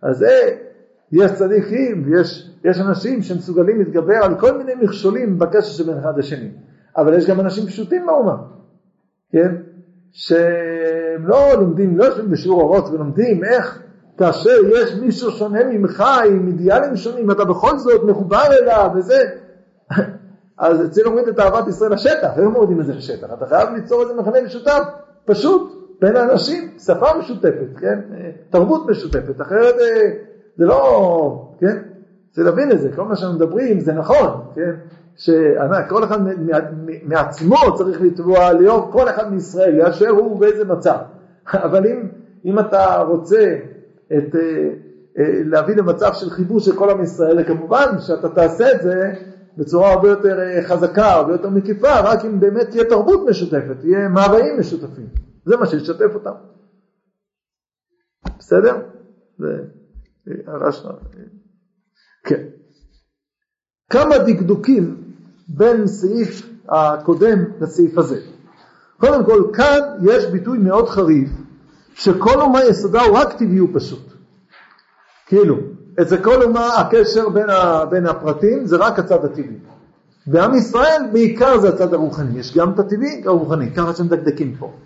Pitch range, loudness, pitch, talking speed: 175-225 Hz, -15 LUFS, 195 Hz, 135 wpm